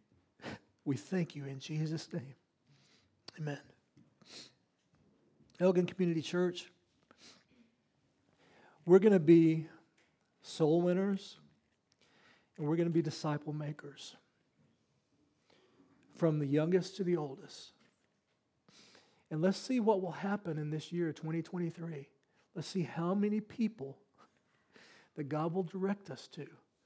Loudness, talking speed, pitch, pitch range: -34 LUFS, 110 wpm, 165 Hz, 150-185 Hz